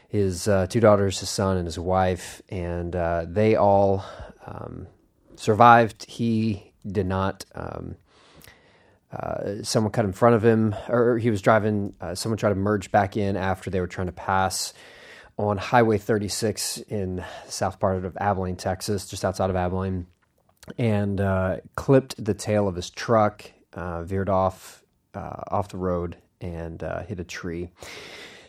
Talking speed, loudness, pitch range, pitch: 160 wpm, -24 LUFS, 95-110 Hz, 100 Hz